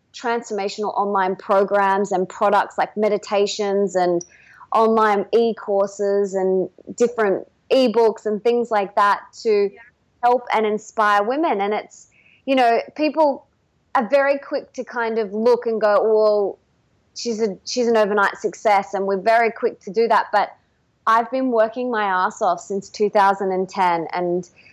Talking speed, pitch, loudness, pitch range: 150 wpm, 215 Hz, -20 LUFS, 195-235 Hz